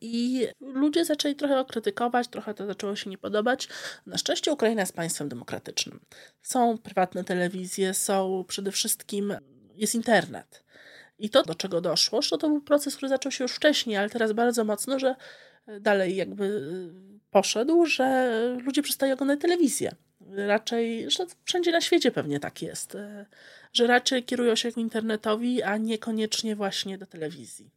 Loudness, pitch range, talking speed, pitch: -26 LUFS, 195-260 Hz, 155 wpm, 220 Hz